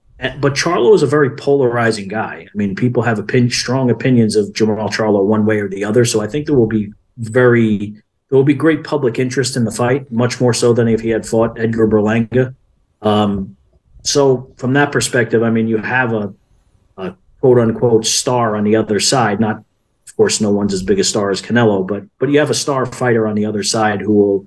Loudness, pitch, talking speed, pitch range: -15 LUFS, 115 Hz, 225 wpm, 105-130 Hz